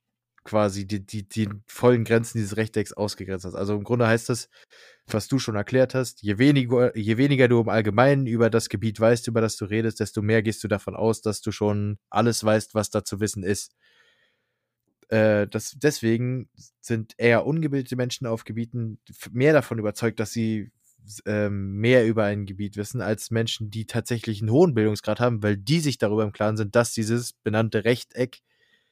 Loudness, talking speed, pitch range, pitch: -24 LUFS, 185 wpm, 105-120 Hz, 110 Hz